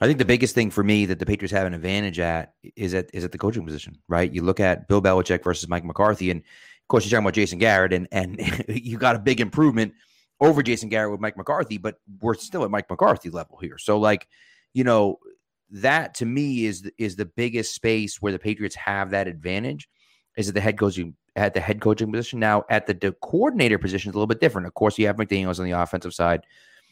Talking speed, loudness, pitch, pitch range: 240 wpm, -23 LUFS, 105 Hz, 95-110 Hz